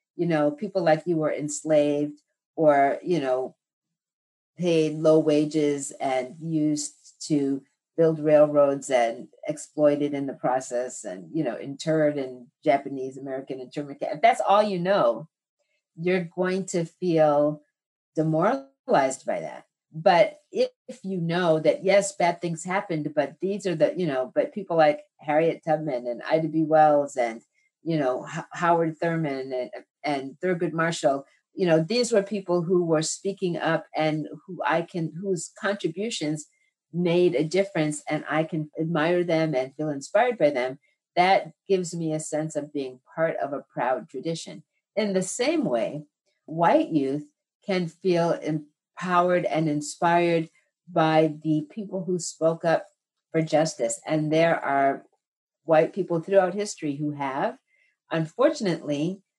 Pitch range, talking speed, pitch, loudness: 150-180 Hz, 145 wpm, 160 Hz, -25 LUFS